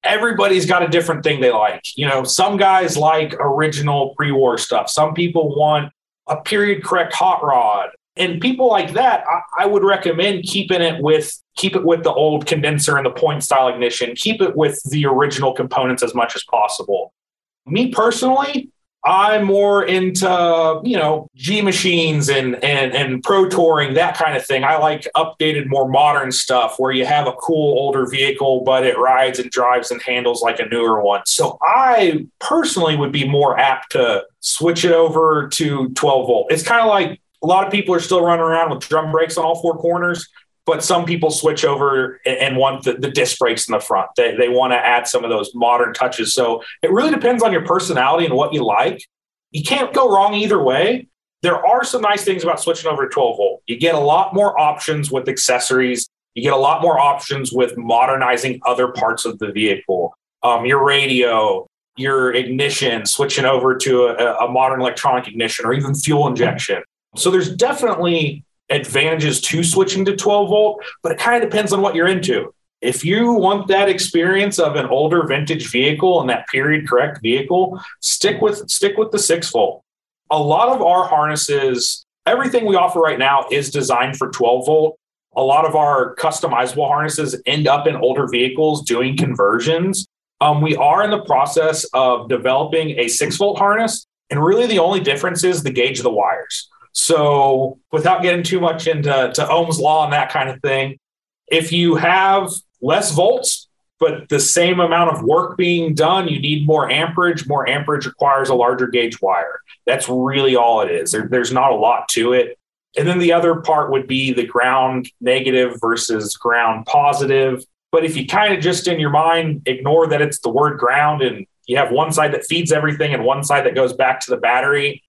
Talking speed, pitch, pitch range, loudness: 195 wpm, 155 Hz, 135-180 Hz, -16 LUFS